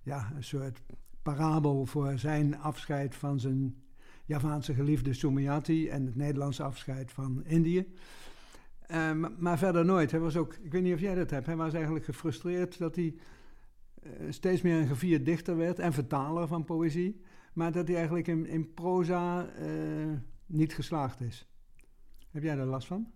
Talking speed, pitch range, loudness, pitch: 170 wpm, 140-170 Hz, -32 LUFS, 155 Hz